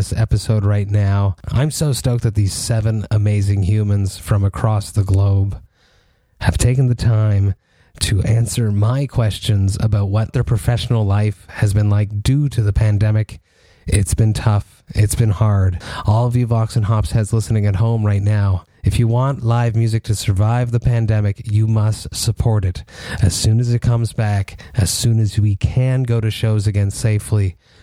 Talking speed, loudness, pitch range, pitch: 175 wpm, -17 LUFS, 100-115 Hz, 105 Hz